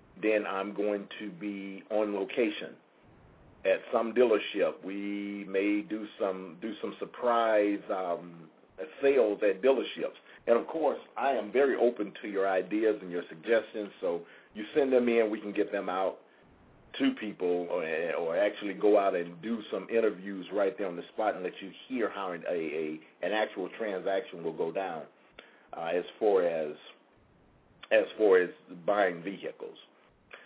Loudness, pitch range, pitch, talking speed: -31 LUFS, 95-115 Hz, 105 Hz, 160 wpm